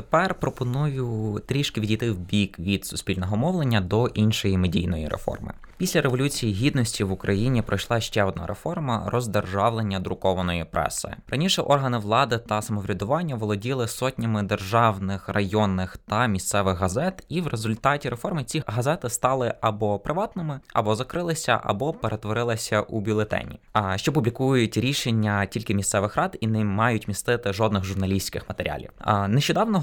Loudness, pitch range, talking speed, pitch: -25 LUFS, 100-130 Hz, 135 wpm, 110 Hz